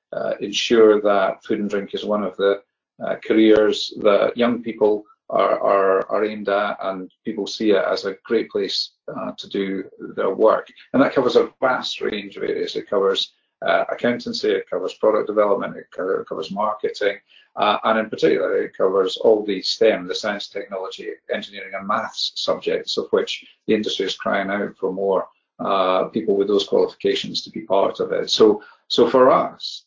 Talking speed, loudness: 185 wpm, -20 LUFS